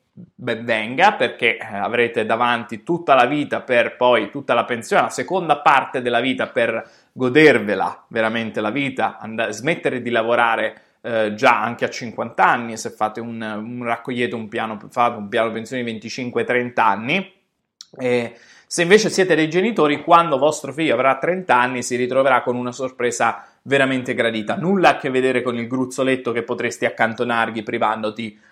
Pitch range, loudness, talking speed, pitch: 115-135 Hz, -19 LUFS, 160 wpm, 120 Hz